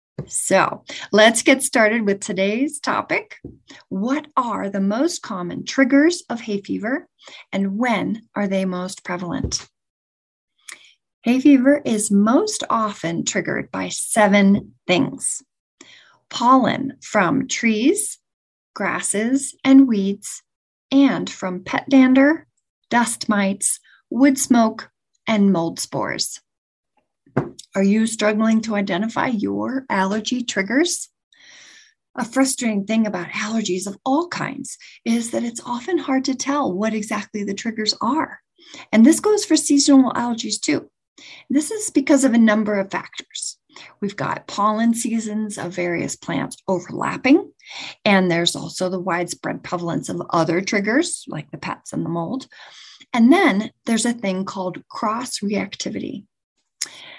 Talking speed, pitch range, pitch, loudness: 130 wpm, 200-270 Hz, 225 Hz, -20 LUFS